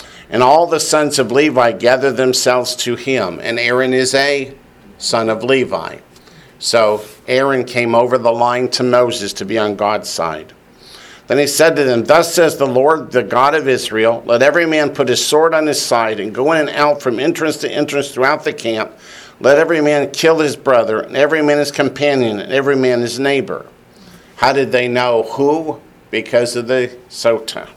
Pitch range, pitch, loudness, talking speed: 120-145 Hz, 130 Hz, -14 LUFS, 190 wpm